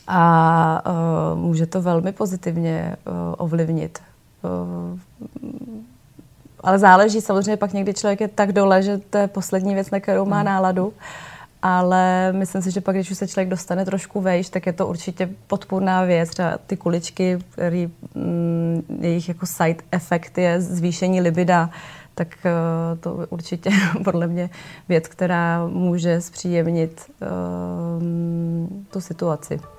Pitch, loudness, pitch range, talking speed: 175 Hz, -21 LUFS, 165-190 Hz, 145 wpm